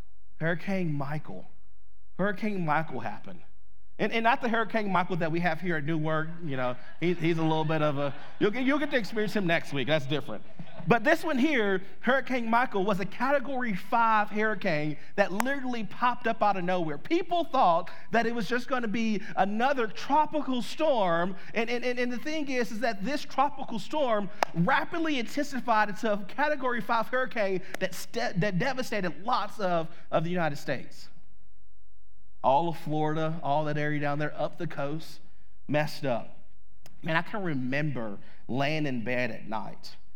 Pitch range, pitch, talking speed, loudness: 155-240 Hz, 195 Hz, 175 wpm, -29 LUFS